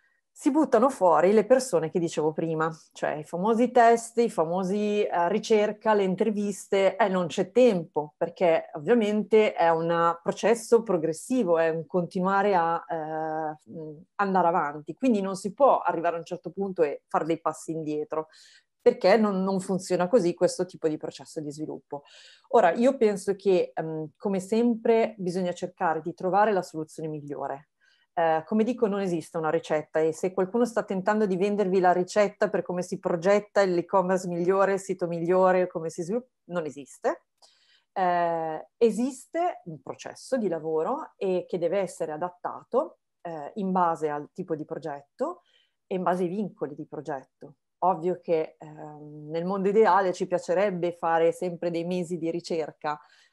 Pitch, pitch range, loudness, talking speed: 180 Hz, 165-205 Hz, -26 LUFS, 160 wpm